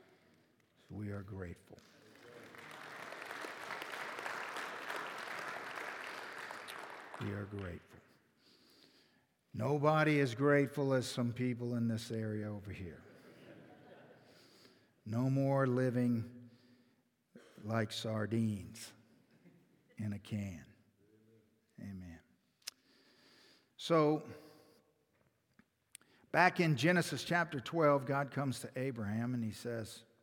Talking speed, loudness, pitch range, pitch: 75 wpm, -37 LUFS, 105-135 Hz, 115 Hz